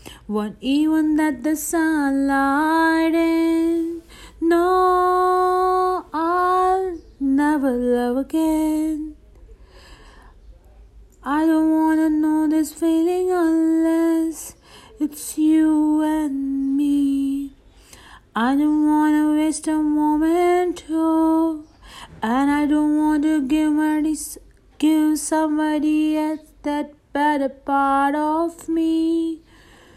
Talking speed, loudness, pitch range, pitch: 85 wpm, -20 LUFS, 295-325 Hz, 310 Hz